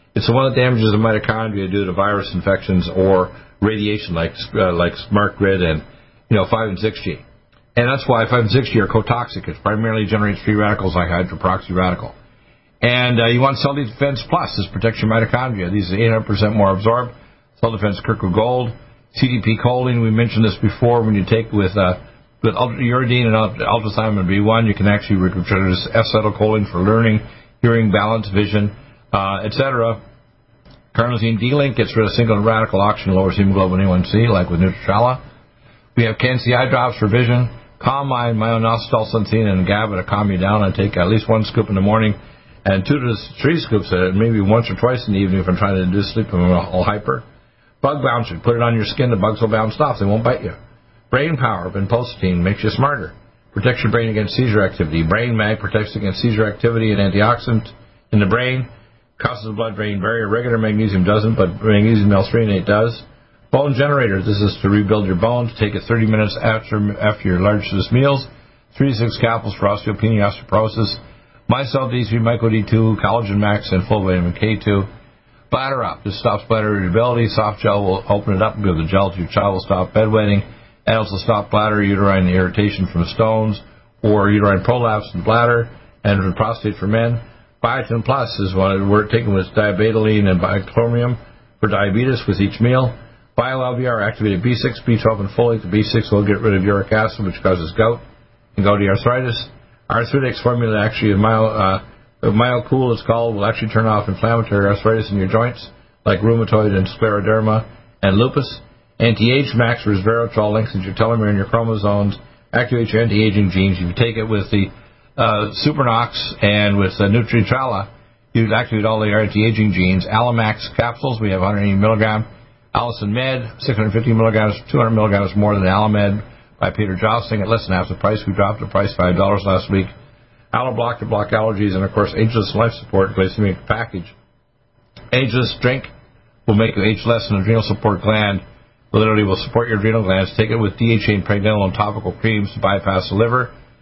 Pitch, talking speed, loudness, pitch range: 110 Hz, 185 wpm, -17 LUFS, 100-120 Hz